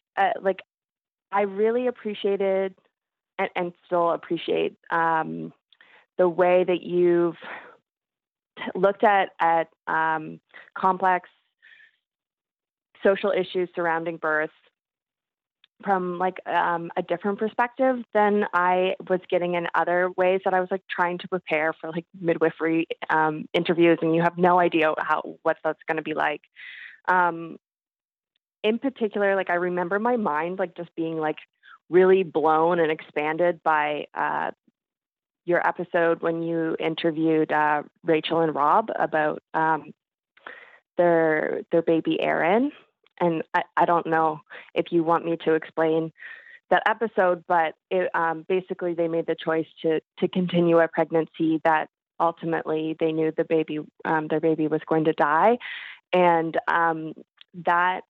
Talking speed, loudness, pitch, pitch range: 140 wpm, -24 LUFS, 170 Hz, 160-185 Hz